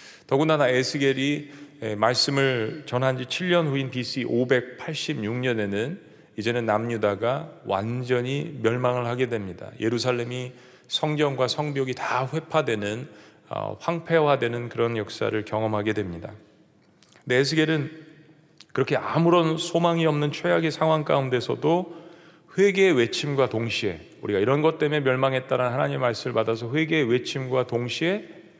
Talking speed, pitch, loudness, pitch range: 290 characters per minute, 130 Hz, -24 LUFS, 120-155 Hz